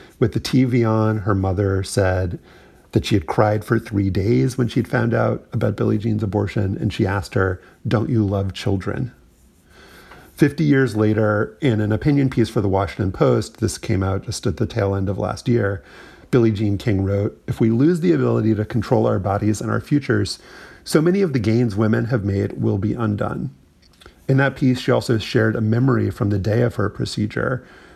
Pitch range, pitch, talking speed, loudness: 100-120 Hz, 110 Hz, 200 wpm, -20 LUFS